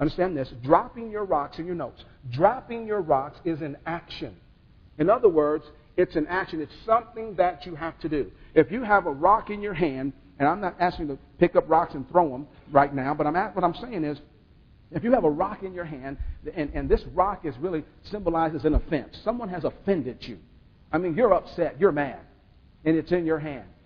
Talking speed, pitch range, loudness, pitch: 220 wpm, 150-195 Hz, -26 LUFS, 165 Hz